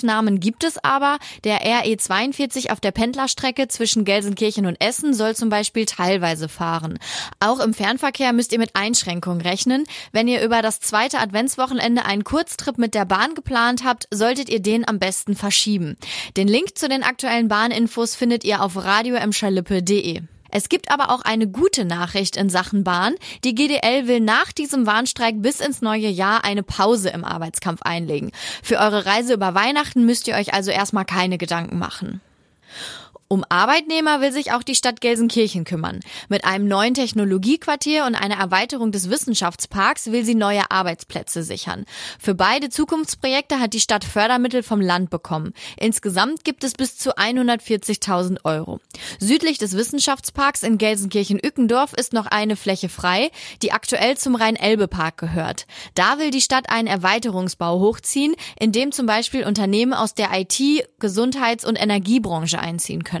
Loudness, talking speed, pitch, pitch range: -19 LUFS, 160 wpm, 220 Hz, 195-250 Hz